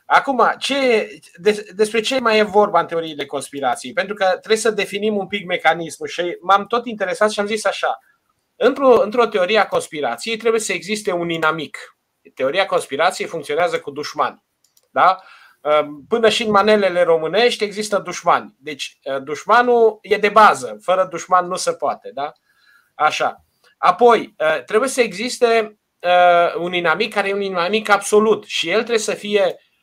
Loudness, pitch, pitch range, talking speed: -18 LUFS, 205 Hz, 175-225 Hz, 155 wpm